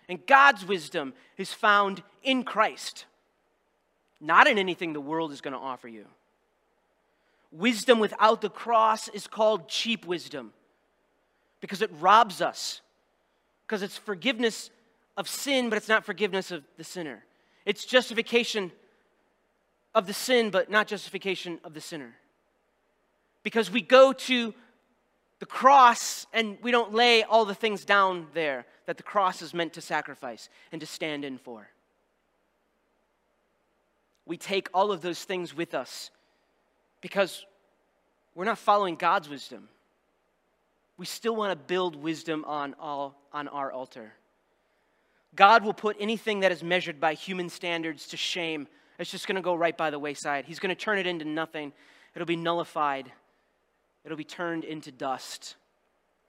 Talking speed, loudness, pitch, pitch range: 150 wpm, -26 LUFS, 185 Hz, 160-215 Hz